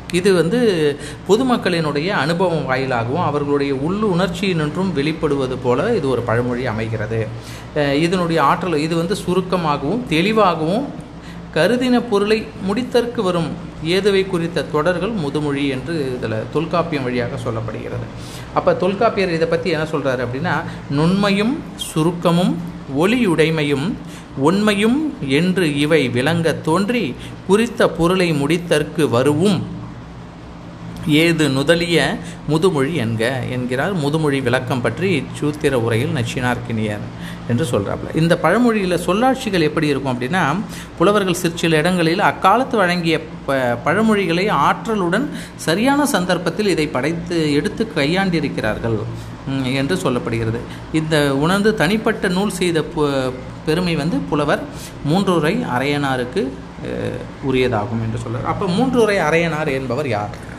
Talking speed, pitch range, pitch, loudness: 105 wpm, 135-185 Hz, 160 Hz, -18 LUFS